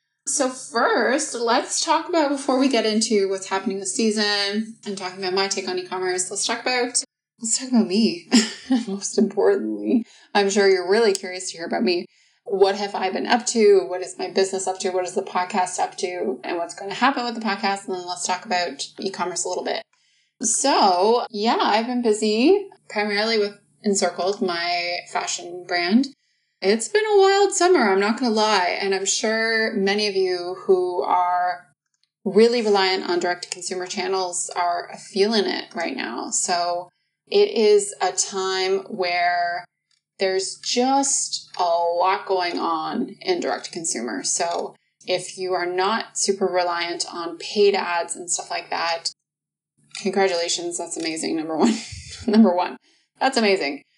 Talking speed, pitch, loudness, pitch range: 170 wpm, 200 Hz, -22 LUFS, 180-240 Hz